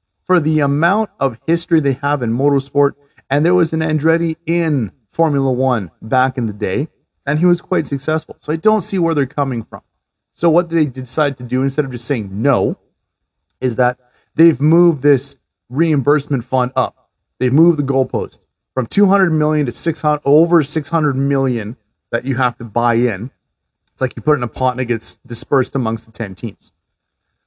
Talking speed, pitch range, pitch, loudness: 195 wpm, 125-160 Hz, 140 Hz, -16 LUFS